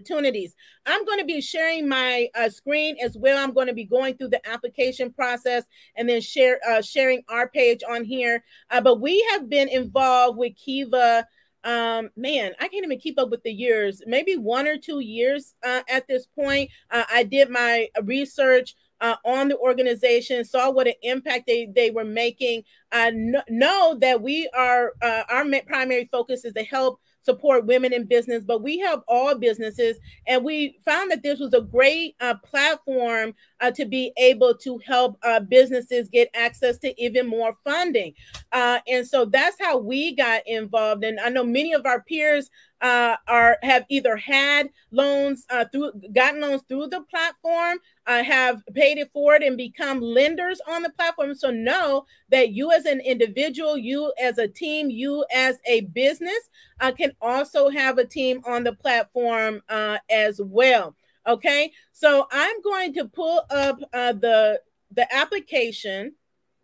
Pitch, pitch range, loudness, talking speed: 255 Hz, 235-285 Hz, -22 LUFS, 175 wpm